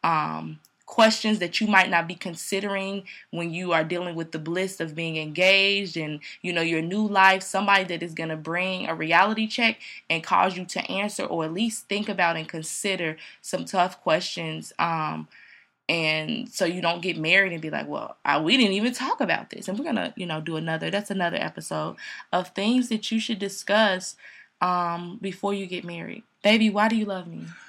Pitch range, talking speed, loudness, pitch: 165-200 Hz, 200 wpm, -24 LUFS, 185 Hz